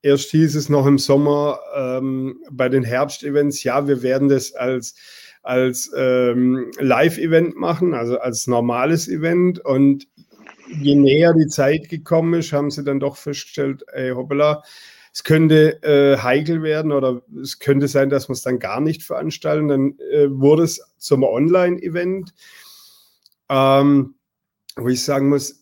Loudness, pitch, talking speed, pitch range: -18 LUFS, 140 Hz, 150 wpm, 130-155 Hz